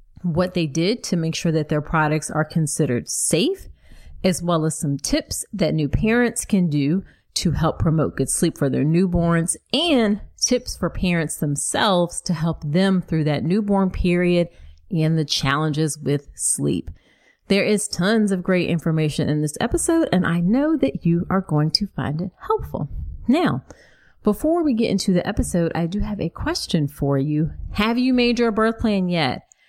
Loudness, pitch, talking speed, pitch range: -21 LUFS, 170 Hz, 180 wpm, 155-205 Hz